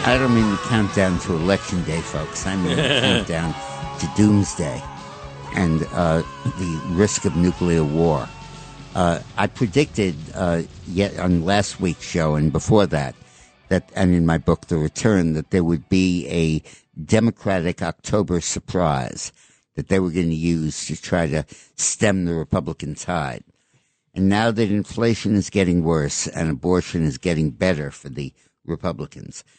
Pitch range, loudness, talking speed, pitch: 80-100 Hz, -21 LUFS, 155 wpm, 90 Hz